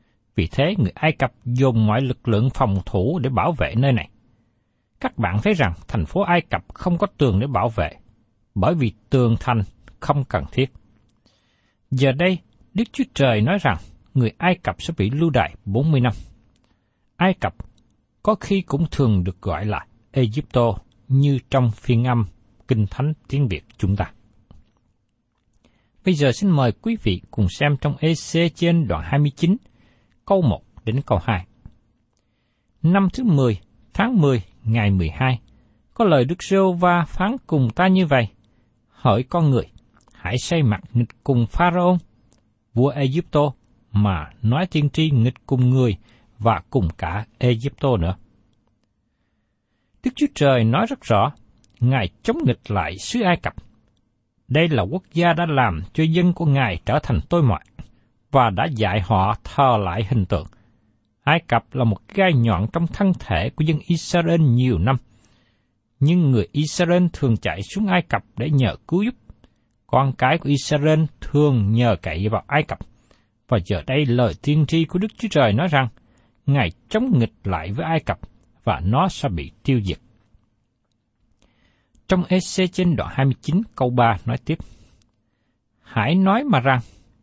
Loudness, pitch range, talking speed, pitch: -20 LUFS, 110-150 Hz, 165 wpm, 120 Hz